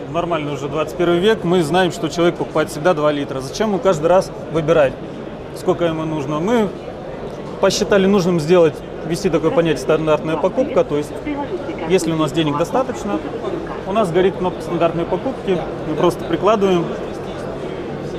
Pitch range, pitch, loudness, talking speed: 160-190 Hz, 170 Hz, -18 LUFS, 150 wpm